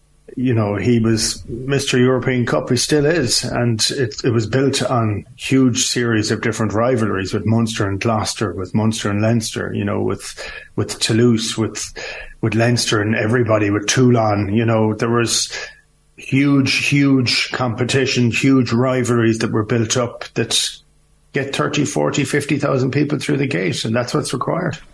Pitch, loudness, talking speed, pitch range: 120 Hz, -17 LUFS, 155 wpm, 110-130 Hz